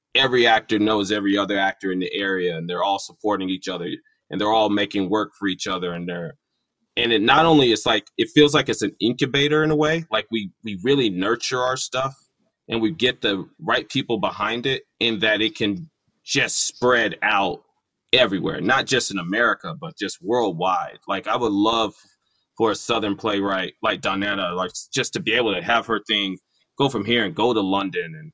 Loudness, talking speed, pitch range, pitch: -21 LUFS, 205 wpm, 100-135 Hz, 110 Hz